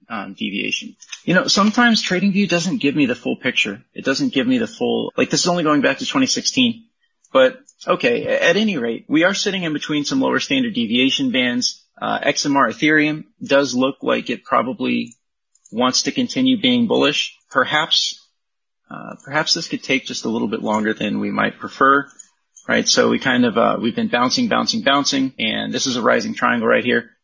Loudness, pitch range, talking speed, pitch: -18 LUFS, 150-255 Hz, 195 wpm, 235 Hz